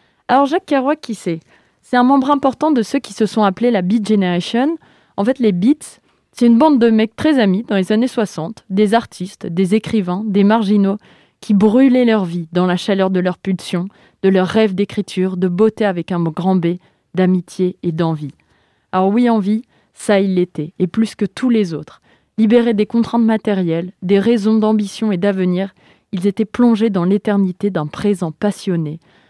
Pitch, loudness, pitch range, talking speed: 205 Hz, -16 LUFS, 185-225 Hz, 190 wpm